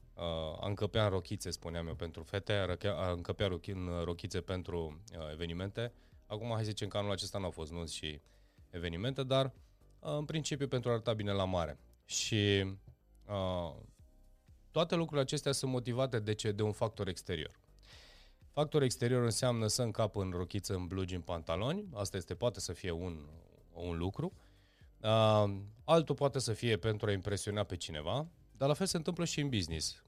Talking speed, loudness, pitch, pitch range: 170 wpm, -36 LUFS, 100 Hz, 90-120 Hz